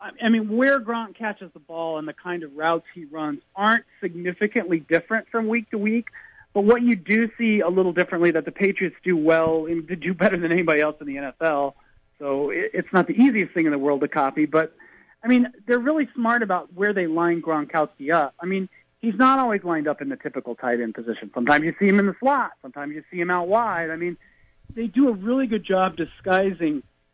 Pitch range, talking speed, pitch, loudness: 155-220 Hz, 225 wpm, 180 Hz, -22 LUFS